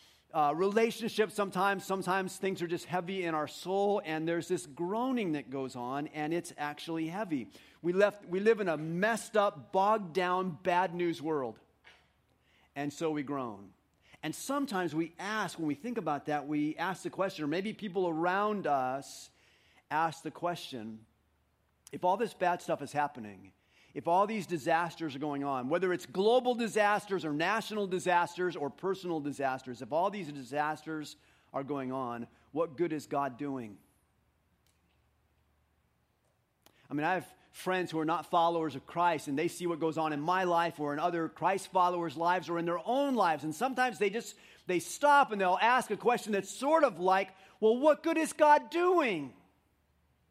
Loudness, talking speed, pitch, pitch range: -32 LUFS, 175 wpm, 170 Hz, 145-195 Hz